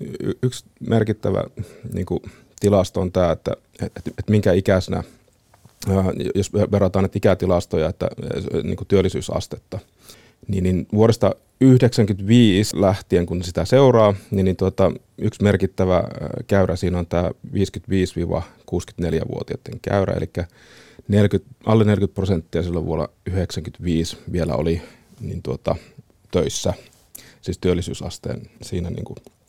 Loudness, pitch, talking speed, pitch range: -21 LUFS, 100 Hz, 110 wpm, 90-110 Hz